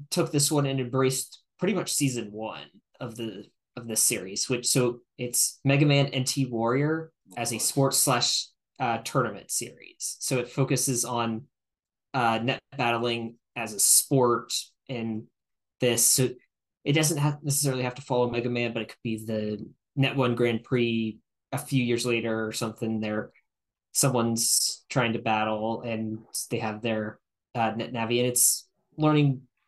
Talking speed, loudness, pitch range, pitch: 160 wpm, -26 LUFS, 115-135 Hz, 120 Hz